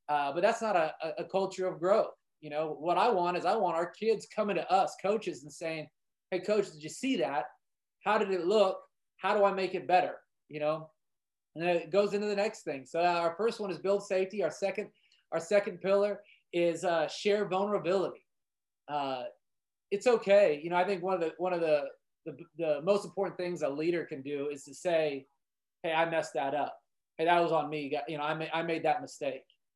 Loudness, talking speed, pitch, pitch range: -31 LUFS, 225 wpm, 175 Hz, 155-200 Hz